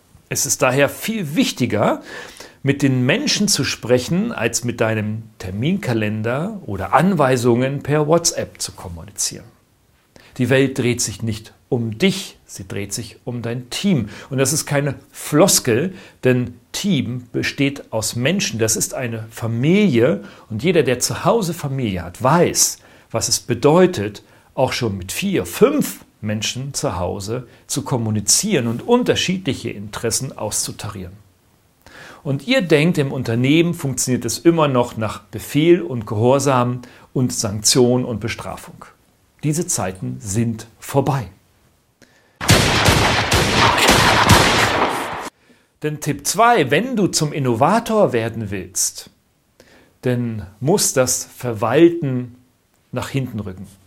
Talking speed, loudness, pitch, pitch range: 120 wpm, -18 LUFS, 125 Hz, 110-145 Hz